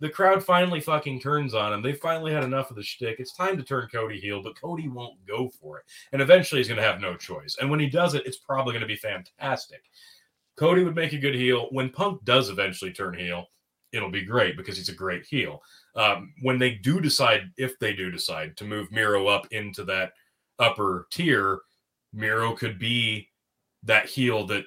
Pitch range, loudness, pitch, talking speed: 105-150 Hz, -25 LUFS, 125 Hz, 215 wpm